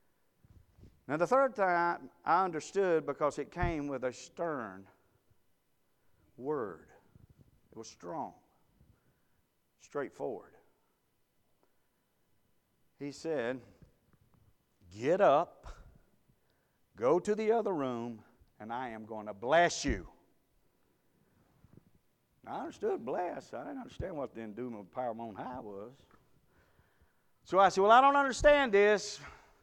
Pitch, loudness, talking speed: 145 Hz, -32 LUFS, 115 wpm